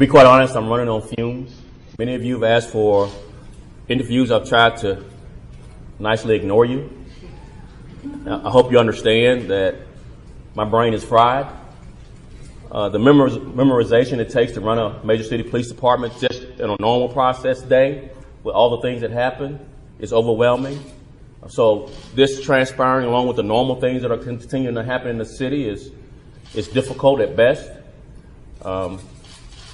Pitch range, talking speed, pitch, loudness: 115-130 Hz, 155 wpm, 120 Hz, -18 LUFS